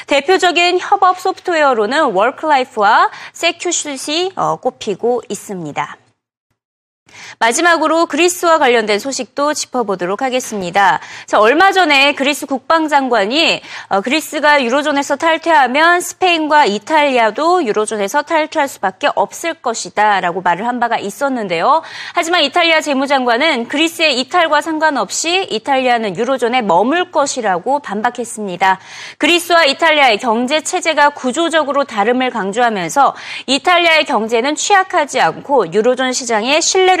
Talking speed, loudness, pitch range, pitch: 345 characters per minute, -13 LUFS, 235-325 Hz, 285 Hz